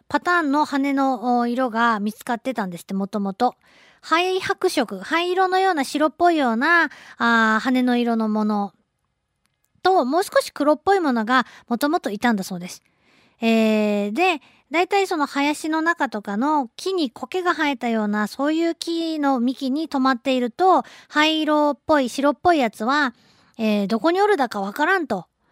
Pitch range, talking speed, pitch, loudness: 230-325 Hz, 325 characters per minute, 275 Hz, -21 LUFS